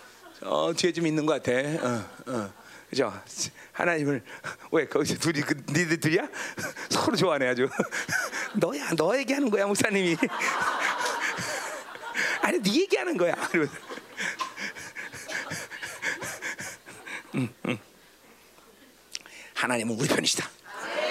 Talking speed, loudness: 200 characters per minute, -28 LUFS